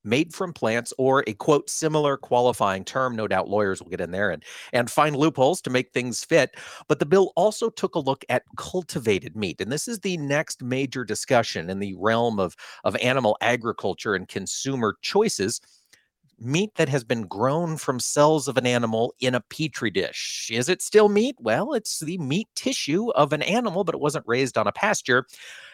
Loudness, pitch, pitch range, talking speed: -24 LUFS, 140 Hz, 120-170 Hz, 195 wpm